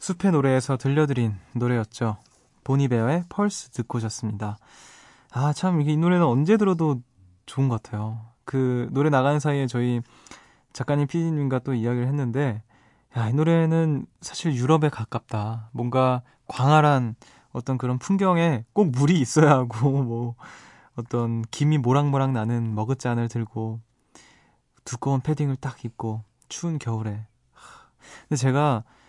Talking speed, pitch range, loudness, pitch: 285 characters per minute, 115-145 Hz, -24 LUFS, 130 Hz